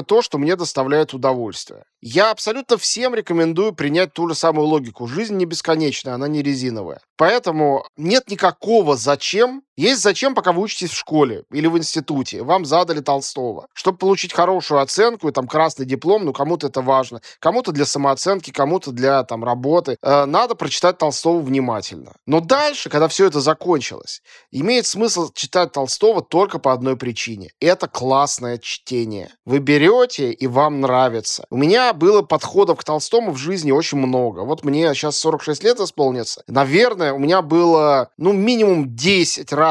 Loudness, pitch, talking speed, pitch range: -18 LUFS, 155 Hz, 160 wpm, 140-190 Hz